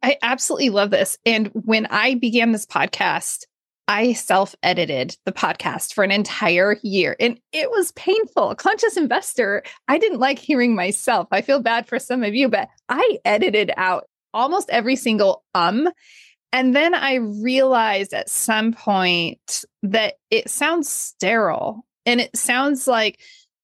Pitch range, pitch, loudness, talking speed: 210-280 Hz, 240 Hz, -19 LUFS, 150 wpm